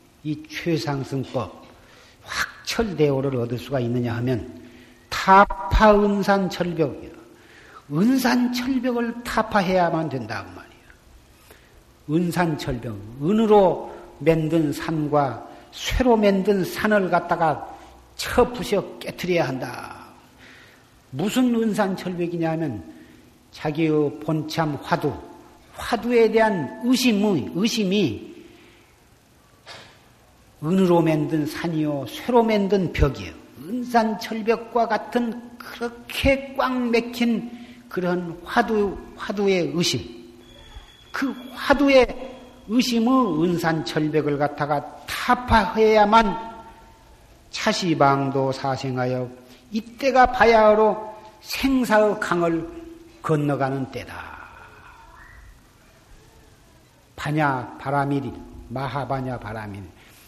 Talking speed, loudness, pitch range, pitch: 200 characters per minute, -22 LUFS, 140-225 Hz, 175 Hz